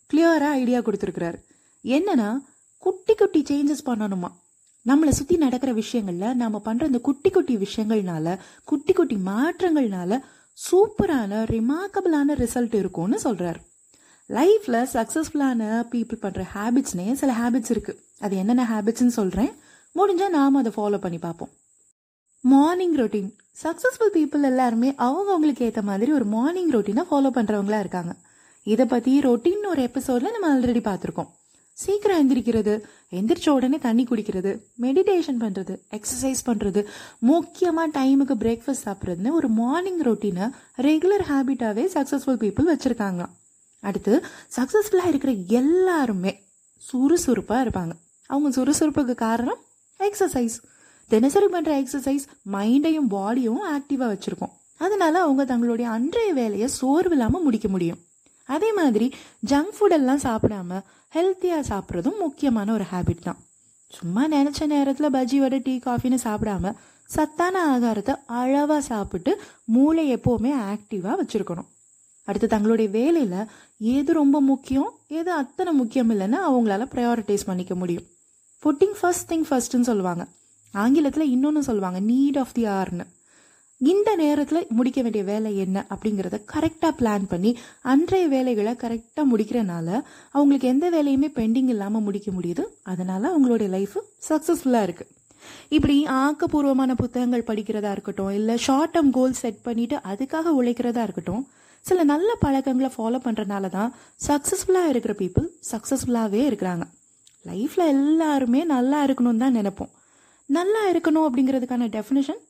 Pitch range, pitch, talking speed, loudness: 220-300 Hz, 255 Hz, 120 wpm, -23 LUFS